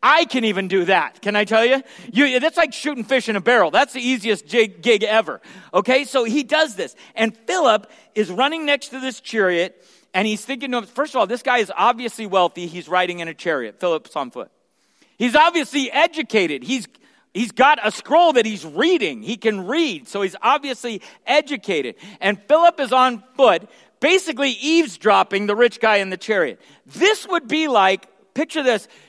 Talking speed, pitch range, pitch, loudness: 190 wpm, 210-290 Hz, 245 Hz, -19 LUFS